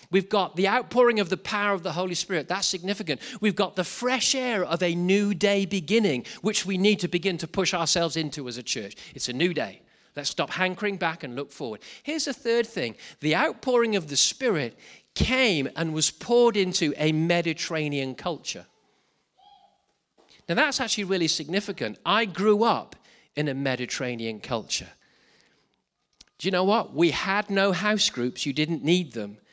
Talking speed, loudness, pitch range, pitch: 180 wpm, -25 LUFS, 160-210 Hz, 190 Hz